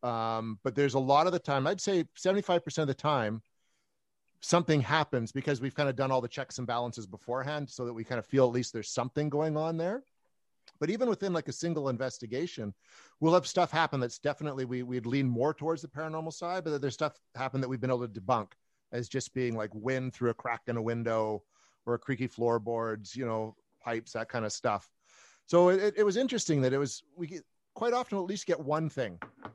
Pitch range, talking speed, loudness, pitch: 120-160 Hz, 225 wpm, -32 LUFS, 135 Hz